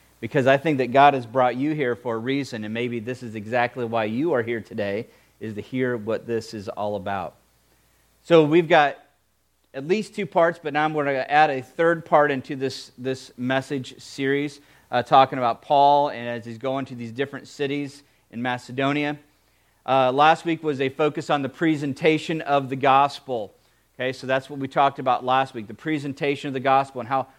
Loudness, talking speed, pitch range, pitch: -23 LUFS, 205 wpm, 120-145 Hz, 135 Hz